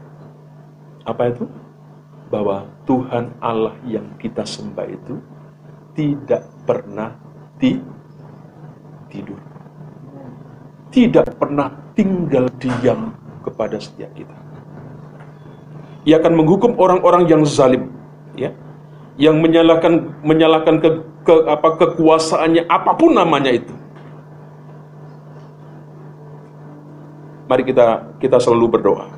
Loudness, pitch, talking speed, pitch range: -15 LUFS, 150 Hz, 85 wpm, 145-160 Hz